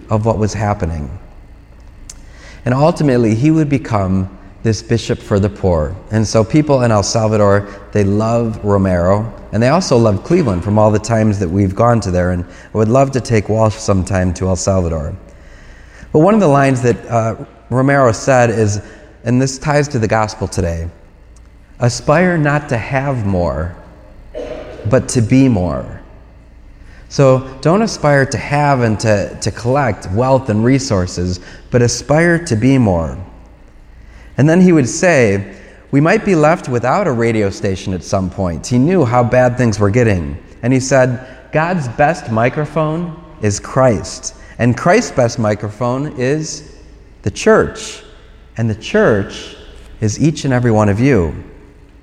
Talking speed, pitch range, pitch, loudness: 160 wpm, 100-130 Hz, 110 Hz, -14 LUFS